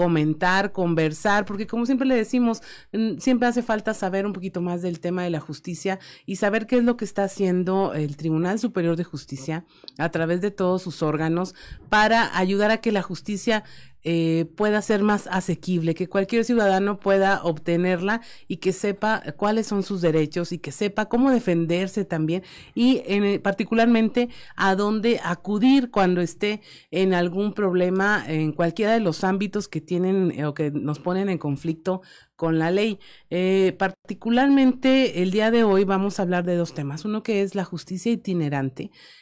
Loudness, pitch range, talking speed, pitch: -23 LUFS, 170-215 Hz, 175 wpm, 190 Hz